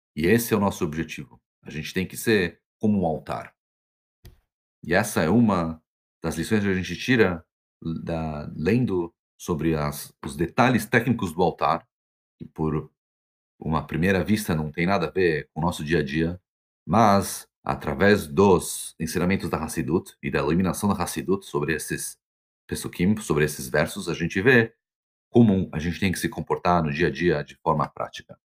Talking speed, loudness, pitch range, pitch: 175 wpm, -24 LUFS, 75-95 Hz, 85 Hz